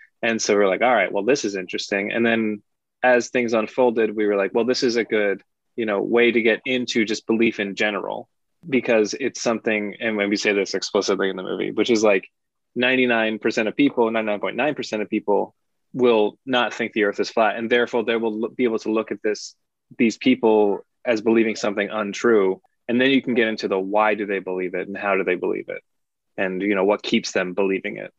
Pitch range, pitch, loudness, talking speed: 105-120 Hz, 110 Hz, -21 LUFS, 220 wpm